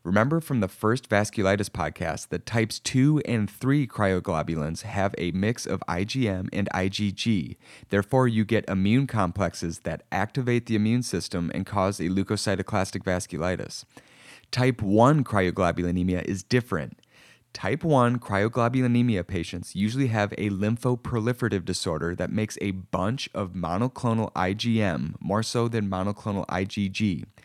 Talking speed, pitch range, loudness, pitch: 130 wpm, 95-115 Hz, -26 LUFS, 100 Hz